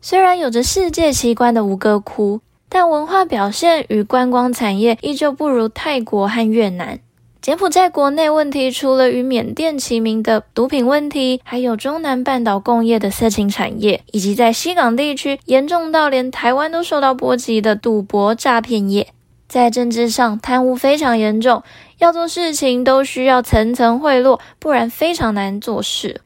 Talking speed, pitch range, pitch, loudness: 265 characters per minute, 225-285 Hz, 250 Hz, -15 LUFS